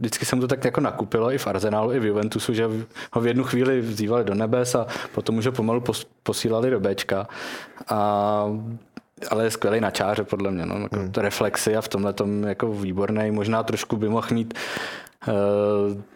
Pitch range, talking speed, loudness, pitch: 105-115 Hz, 200 wpm, -24 LUFS, 110 Hz